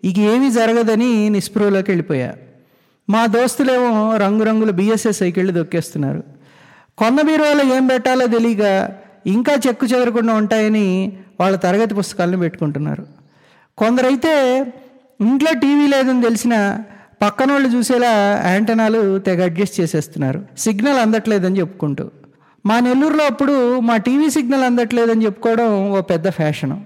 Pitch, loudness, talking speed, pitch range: 220 Hz, -16 LUFS, 110 wpm, 195-250 Hz